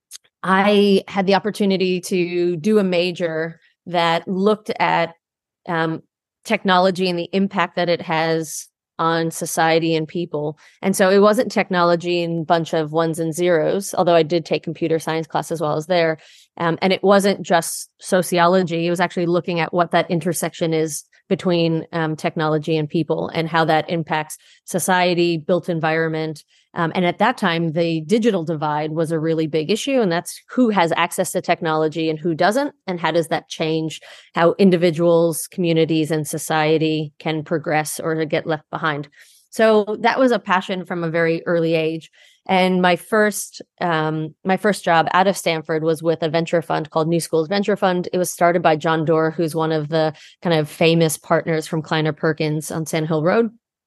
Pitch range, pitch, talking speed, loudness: 160-185 Hz, 170 Hz, 180 wpm, -19 LUFS